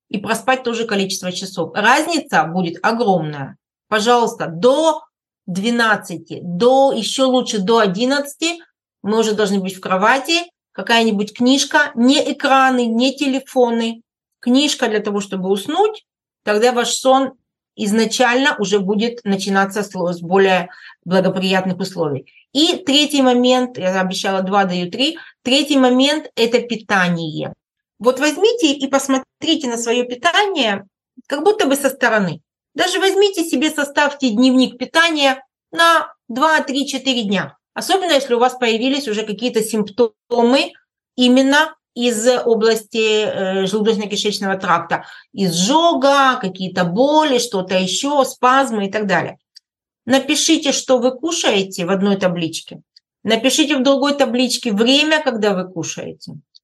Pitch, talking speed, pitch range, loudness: 245 Hz, 120 wpm, 200-275 Hz, -16 LUFS